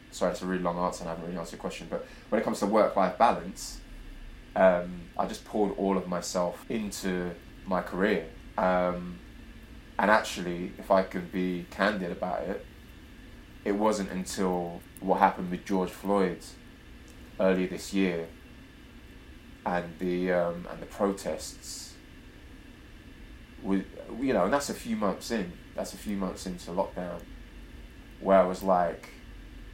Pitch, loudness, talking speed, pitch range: 90 Hz, -30 LUFS, 155 wpm, 85-95 Hz